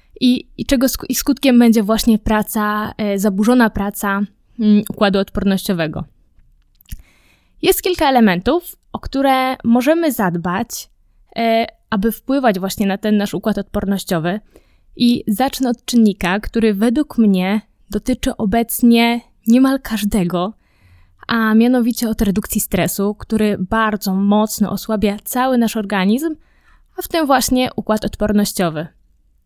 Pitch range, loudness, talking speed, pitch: 200-245 Hz, -16 LUFS, 110 wpm, 220 Hz